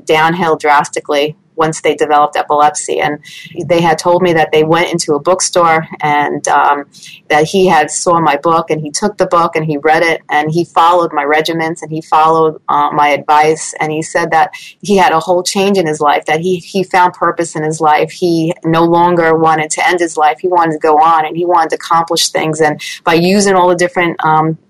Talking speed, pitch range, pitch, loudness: 220 wpm, 155-175 Hz, 160 Hz, -11 LUFS